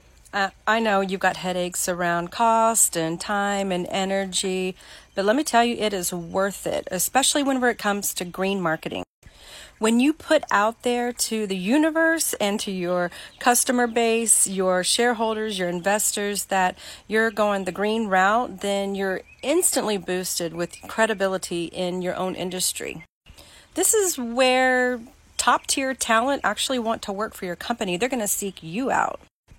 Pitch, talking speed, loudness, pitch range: 205 Hz, 160 wpm, -22 LUFS, 185-240 Hz